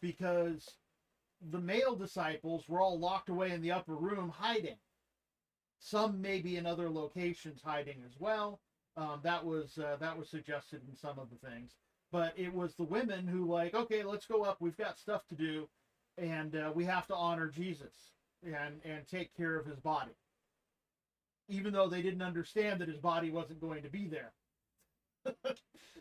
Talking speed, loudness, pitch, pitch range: 175 wpm, -38 LUFS, 170 Hz, 155-185 Hz